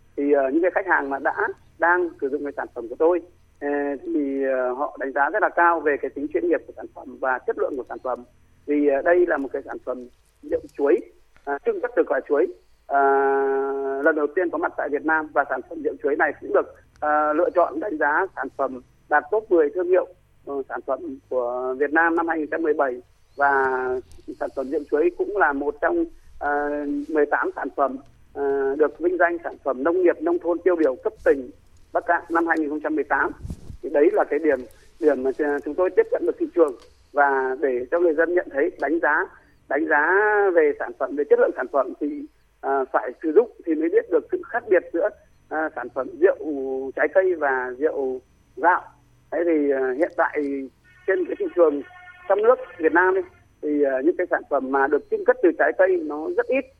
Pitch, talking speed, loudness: 165 Hz, 220 wpm, -23 LUFS